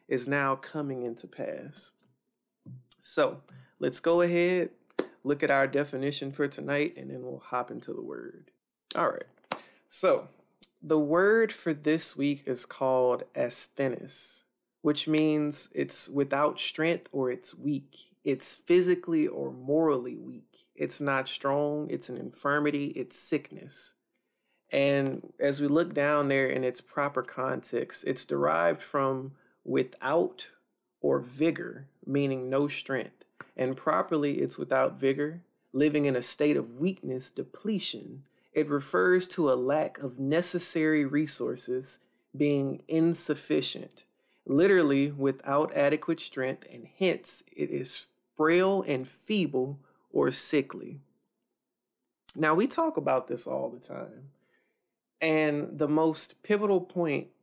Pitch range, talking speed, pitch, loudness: 135-160 Hz, 125 wpm, 145 Hz, -29 LUFS